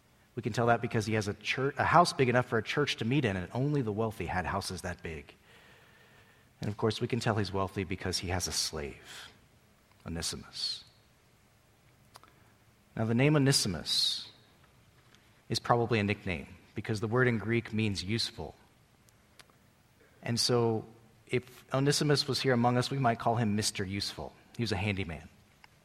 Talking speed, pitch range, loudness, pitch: 170 wpm, 100-120 Hz, -31 LUFS, 115 Hz